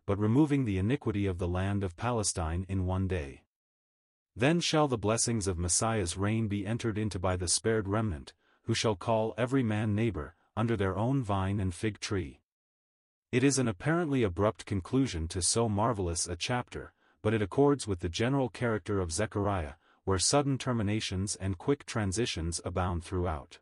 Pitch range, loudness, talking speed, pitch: 95-115 Hz, -31 LUFS, 170 wpm, 105 Hz